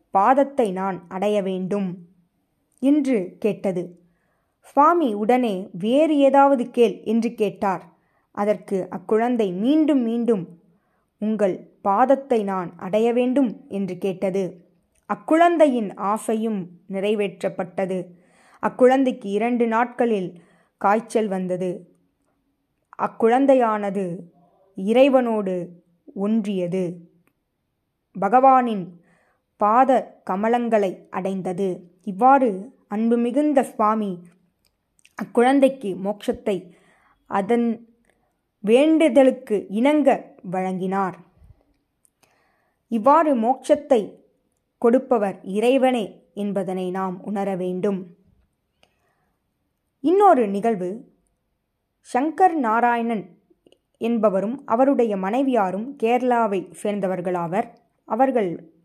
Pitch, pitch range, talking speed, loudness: 210 Hz, 190-245 Hz, 70 wpm, -21 LUFS